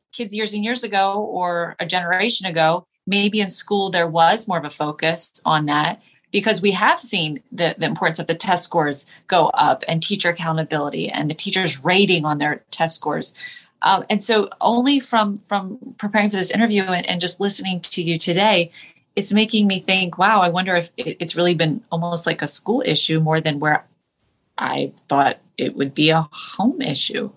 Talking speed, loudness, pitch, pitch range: 195 wpm, -19 LUFS, 180 Hz, 165-210 Hz